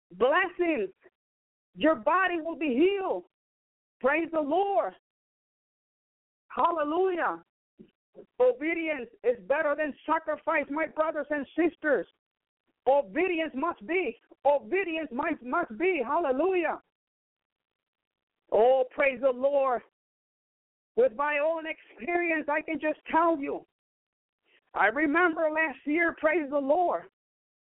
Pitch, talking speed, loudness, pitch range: 315 Hz, 100 wpm, -28 LUFS, 290-345 Hz